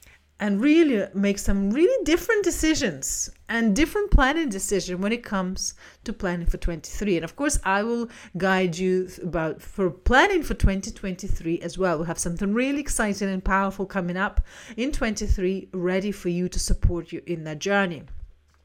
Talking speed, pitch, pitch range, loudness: 165 wpm, 195 Hz, 180-230 Hz, -25 LUFS